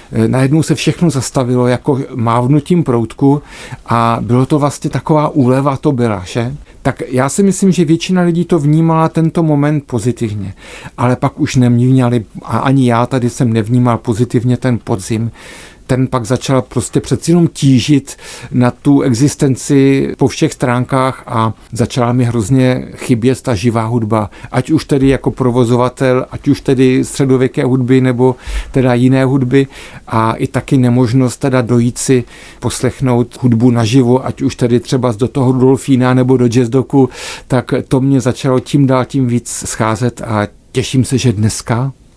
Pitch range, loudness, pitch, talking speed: 120-140 Hz, -13 LUFS, 130 Hz, 160 wpm